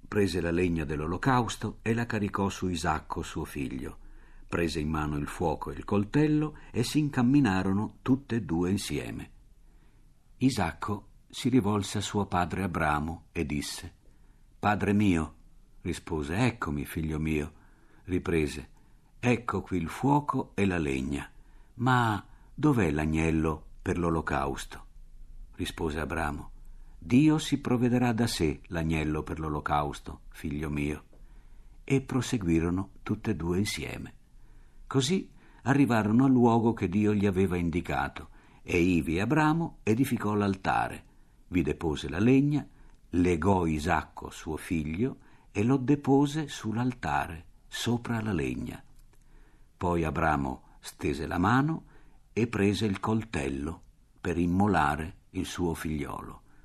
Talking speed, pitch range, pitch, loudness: 125 wpm, 80-120 Hz, 95 Hz, -29 LUFS